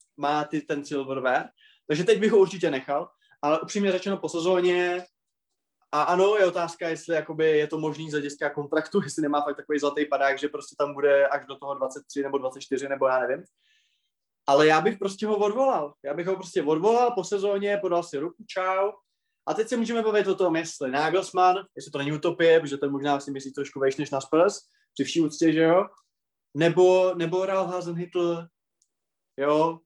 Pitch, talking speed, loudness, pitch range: 165 Hz, 190 wpm, -25 LUFS, 145-190 Hz